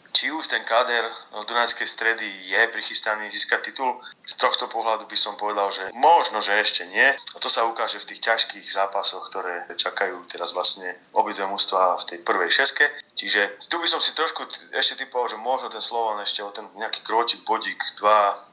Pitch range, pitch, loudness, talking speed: 95-115 Hz, 105 Hz, -21 LUFS, 190 wpm